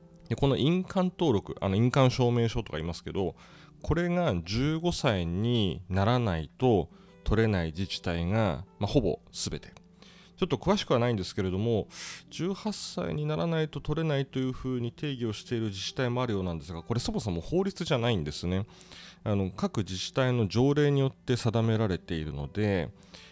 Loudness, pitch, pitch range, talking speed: -29 LUFS, 115 Hz, 95-145 Hz, 360 characters per minute